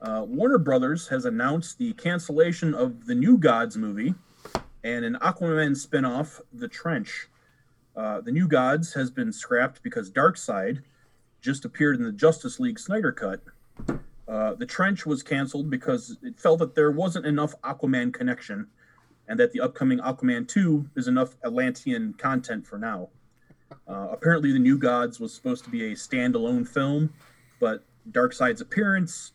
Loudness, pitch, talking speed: -25 LUFS, 160 Hz, 155 wpm